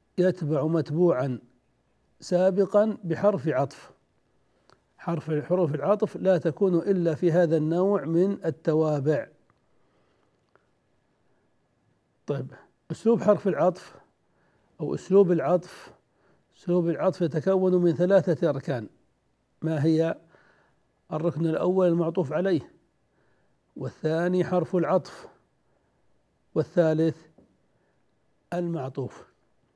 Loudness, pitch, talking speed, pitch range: -25 LUFS, 170 Hz, 80 wpm, 160-185 Hz